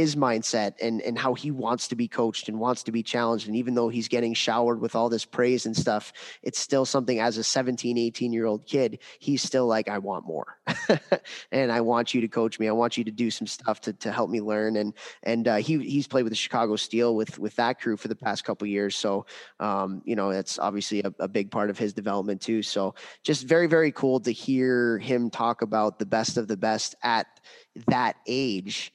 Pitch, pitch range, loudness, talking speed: 115 Hz, 110-125 Hz, -26 LUFS, 235 wpm